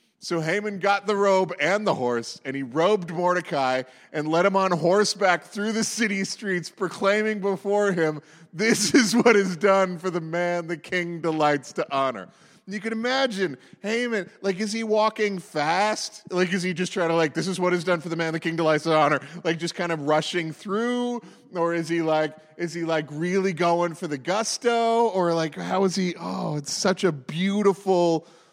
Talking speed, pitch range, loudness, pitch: 200 wpm, 165-200 Hz, -24 LUFS, 180 Hz